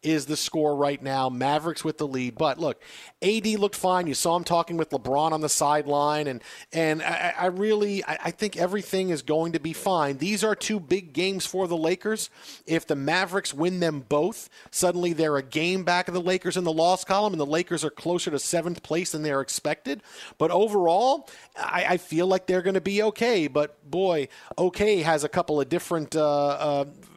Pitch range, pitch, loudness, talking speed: 150-185 Hz, 170 Hz, -25 LUFS, 210 wpm